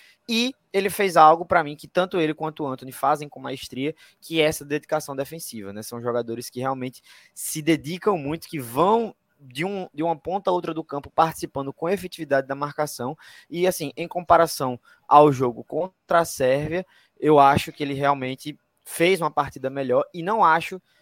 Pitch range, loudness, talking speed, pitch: 140-175 Hz, -23 LUFS, 185 wpm, 155 Hz